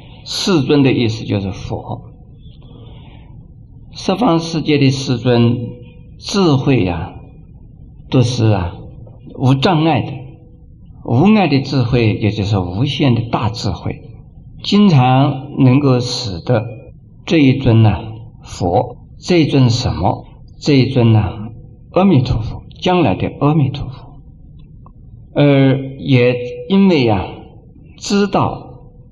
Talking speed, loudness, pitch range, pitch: 165 characters per minute, -15 LUFS, 115-140 Hz, 125 Hz